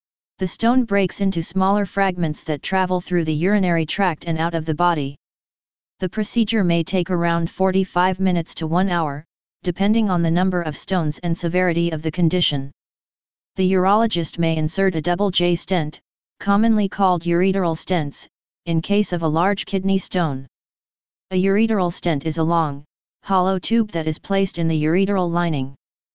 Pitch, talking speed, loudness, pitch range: 175 Hz, 165 wpm, -20 LUFS, 165-190 Hz